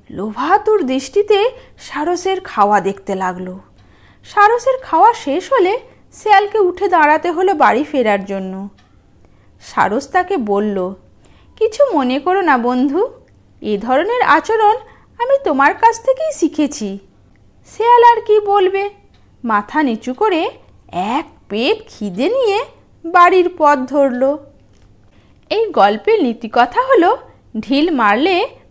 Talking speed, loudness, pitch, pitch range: 110 wpm, -14 LUFS, 335 Hz, 255-425 Hz